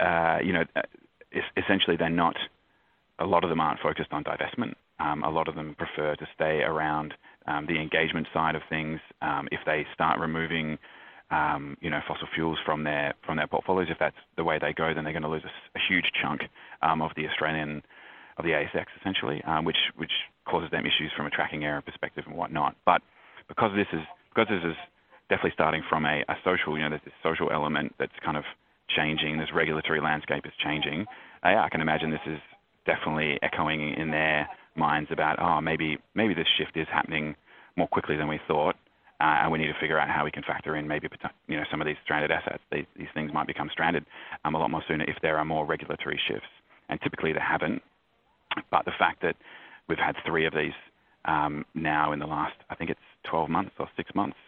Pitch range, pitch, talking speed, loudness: 75-80 Hz, 75 Hz, 215 wpm, -28 LUFS